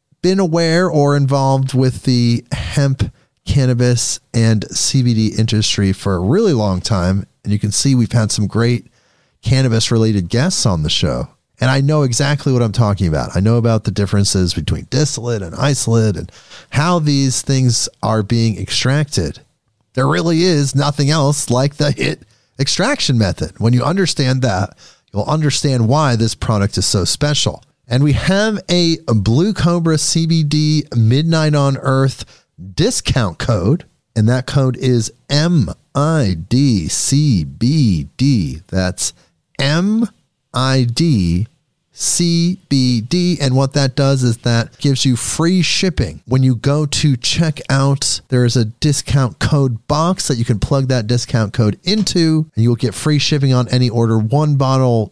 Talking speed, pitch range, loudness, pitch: 155 wpm, 115-145 Hz, -15 LUFS, 130 Hz